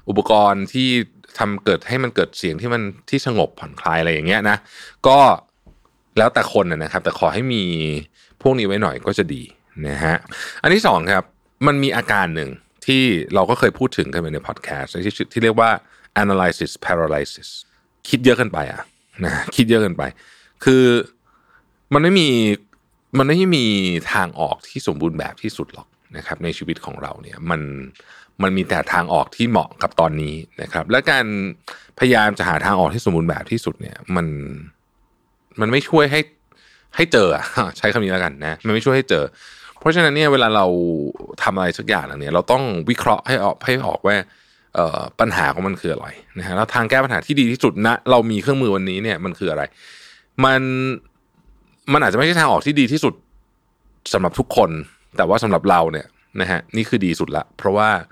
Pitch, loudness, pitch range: 110 Hz, -18 LUFS, 90-130 Hz